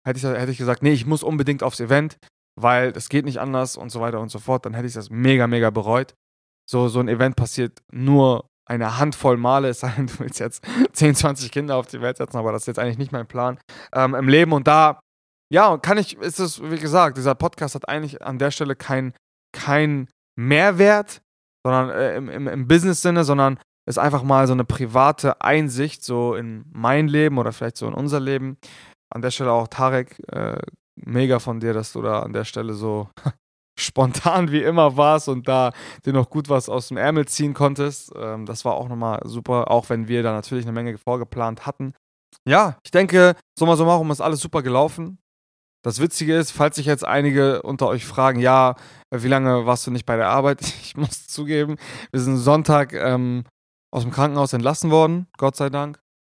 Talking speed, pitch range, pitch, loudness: 205 wpm, 120-150 Hz, 130 Hz, -20 LUFS